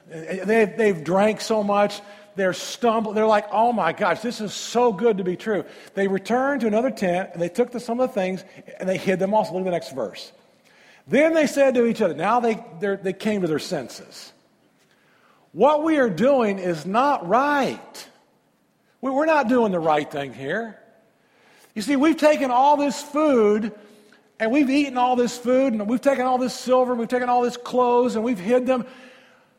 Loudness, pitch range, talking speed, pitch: -21 LUFS, 200-250 Hz, 200 wpm, 225 Hz